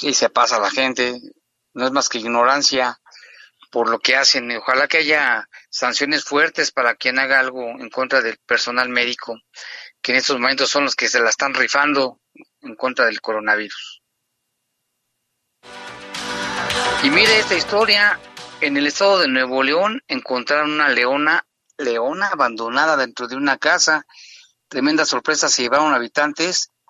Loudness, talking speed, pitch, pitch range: -17 LUFS, 150 wpm, 135 Hz, 125-150 Hz